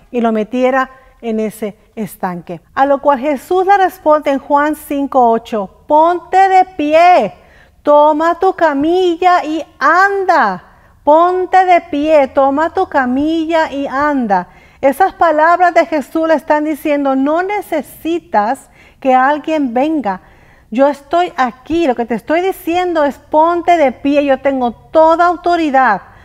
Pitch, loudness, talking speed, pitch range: 300 Hz, -13 LUFS, 135 wpm, 265-340 Hz